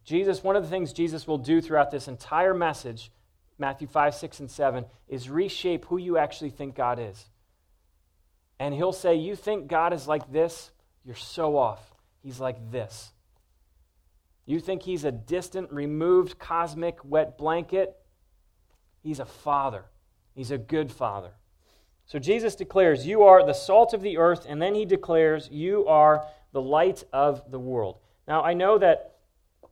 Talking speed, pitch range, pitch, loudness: 165 wpm, 115-170 Hz, 145 Hz, -25 LUFS